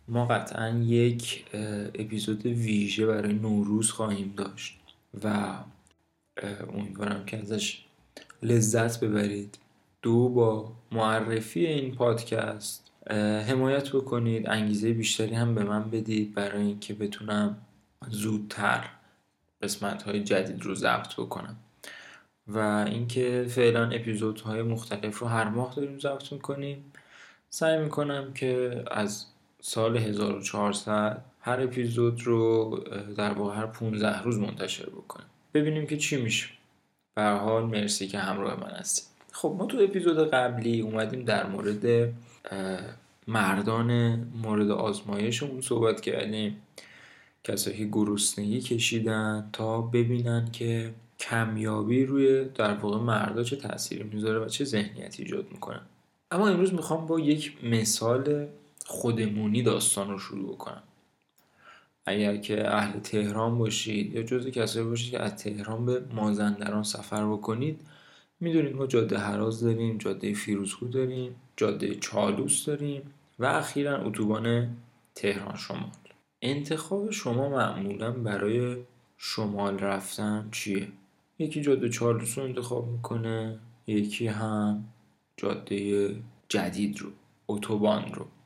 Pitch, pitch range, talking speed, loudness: 110 Hz, 105-120 Hz, 120 wpm, -29 LUFS